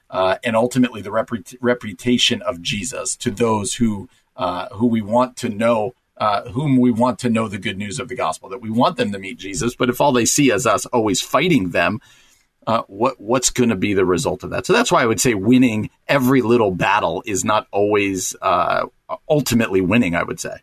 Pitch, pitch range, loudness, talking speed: 120 Hz, 110-125 Hz, -18 LUFS, 220 wpm